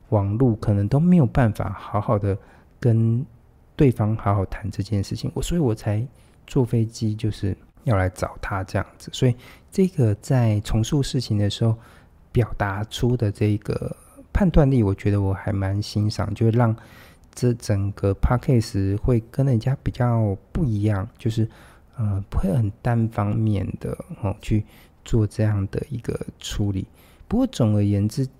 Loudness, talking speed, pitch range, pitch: -23 LUFS, 240 characters per minute, 100-125 Hz, 110 Hz